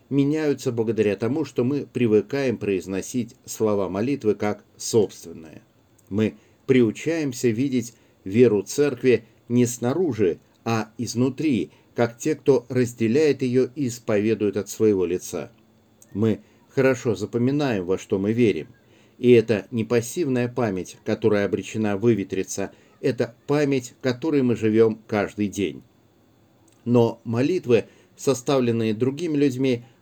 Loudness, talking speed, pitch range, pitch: -23 LUFS, 115 wpm, 110-130 Hz, 115 Hz